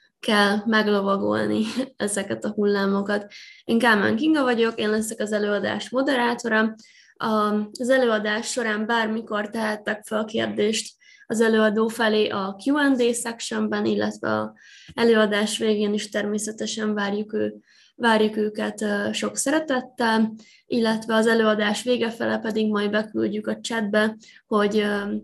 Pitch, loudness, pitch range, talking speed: 215 Hz, -23 LUFS, 210-230 Hz, 120 wpm